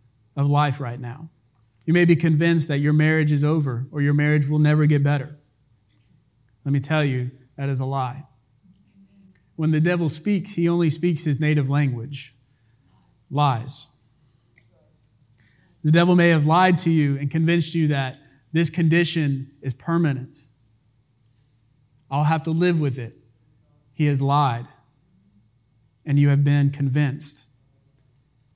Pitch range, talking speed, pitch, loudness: 125-155 Hz, 145 wpm, 140 Hz, -20 LUFS